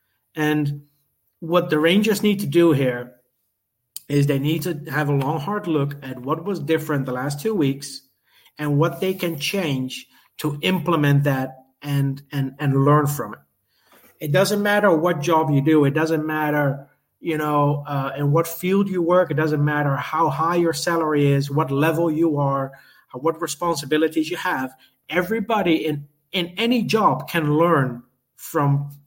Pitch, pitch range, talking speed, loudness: 150 Hz, 140-170 Hz, 165 wpm, -21 LUFS